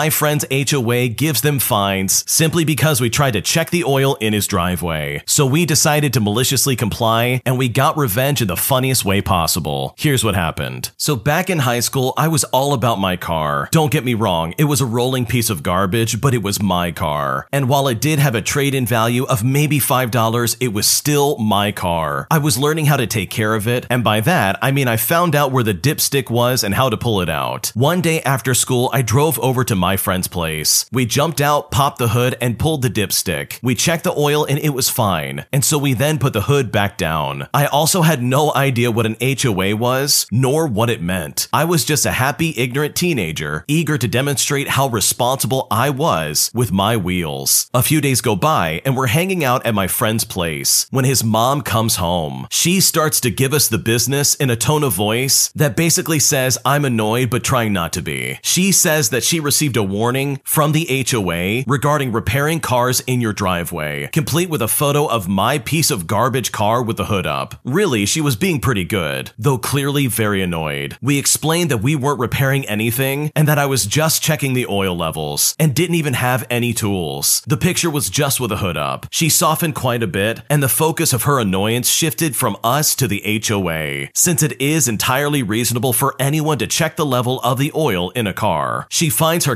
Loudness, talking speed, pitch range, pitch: -16 LUFS, 215 wpm, 110-145 Hz, 130 Hz